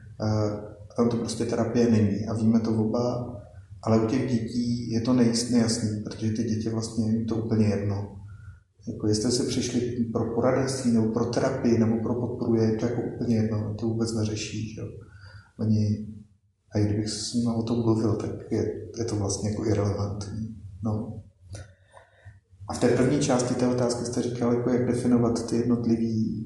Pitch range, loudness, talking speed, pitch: 105-120 Hz, -26 LUFS, 180 wpm, 115 Hz